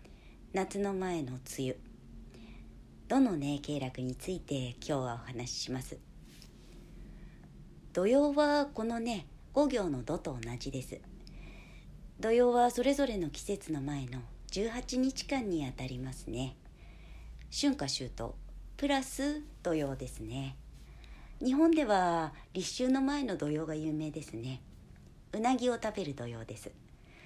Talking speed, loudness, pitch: 220 characters per minute, -34 LUFS, 155 Hz